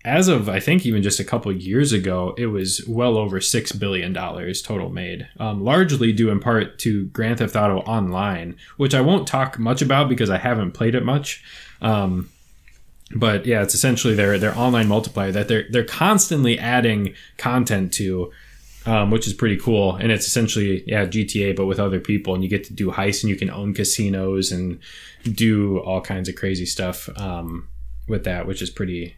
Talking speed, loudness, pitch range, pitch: 195 wpm, -20 LUFS, 95-115 Hz, 105 Hz